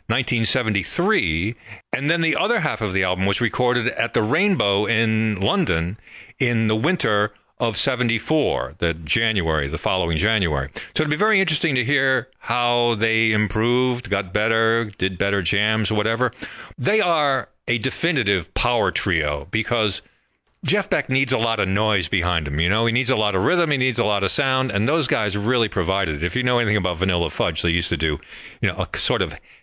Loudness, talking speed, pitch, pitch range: -21 LUFS, 190 wpm, 110 Hz, 95-125 Hz